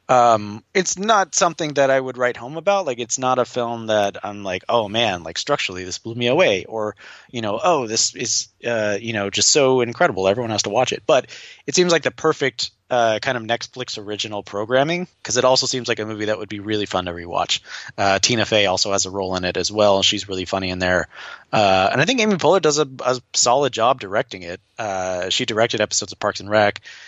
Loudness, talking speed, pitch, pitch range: -19 LUFS, 235 wpm, 115 Hz, 105-130 Hz